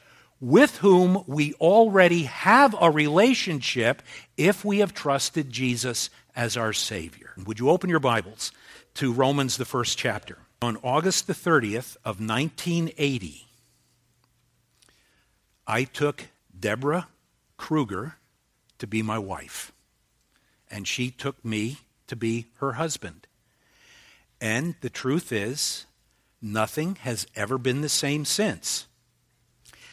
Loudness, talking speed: -24 LUFS, 115 wpm